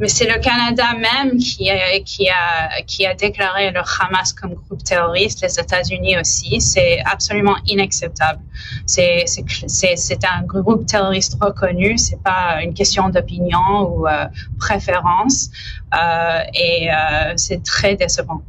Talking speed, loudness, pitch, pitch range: 150 wpm, -16 LUFS, 190 Hz, 175-205 Hz